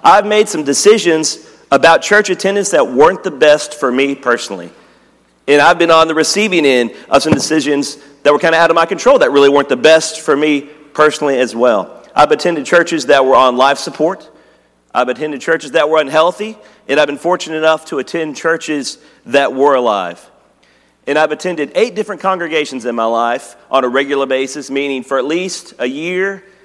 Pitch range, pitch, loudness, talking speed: 135-165 Hz, 150 Hz, -12 LUFS, 195 wpm